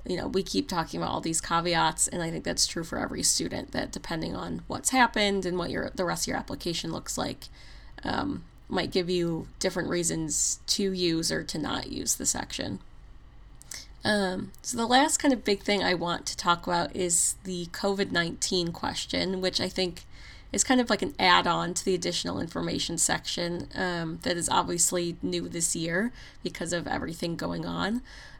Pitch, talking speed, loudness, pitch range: 180 Hz, 190 wpm, -28 LUFS, 170-200 Hz